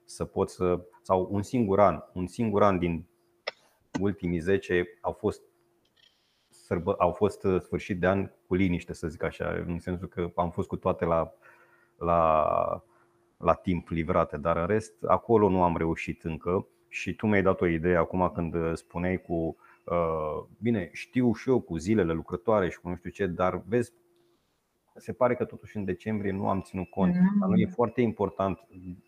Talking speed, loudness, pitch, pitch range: 175 wpm, -28 LUFS, 90 Hz, 85-105 Hz